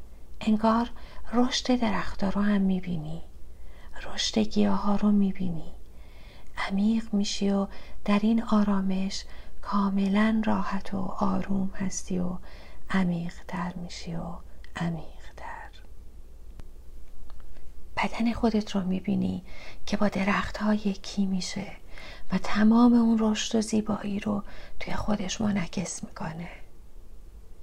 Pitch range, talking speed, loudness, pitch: 175-210 Hz, 110 wpm, -28 LUFS, 195 Hz